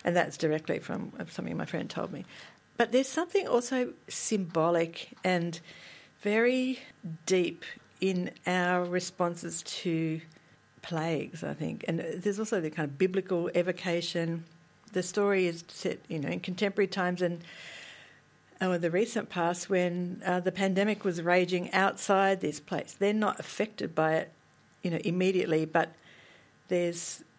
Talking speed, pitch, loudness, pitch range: 145 wpm, 180 Hz, -30 LUFS, 170-195 Hz